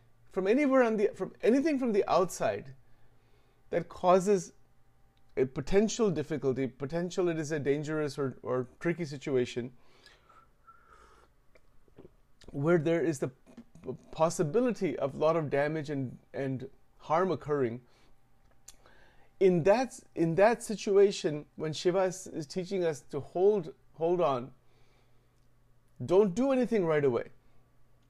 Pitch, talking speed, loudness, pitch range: 160 Hz, 120 wpm, -30 LUFS, 125-190 Hz